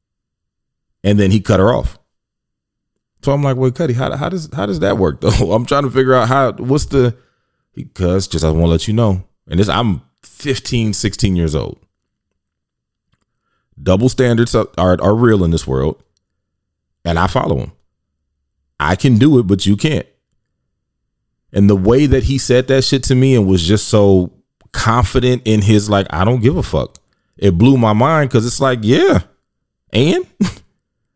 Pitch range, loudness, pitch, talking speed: 95-130 Hz, -14 LUFS, 105 Hz, 180 wpm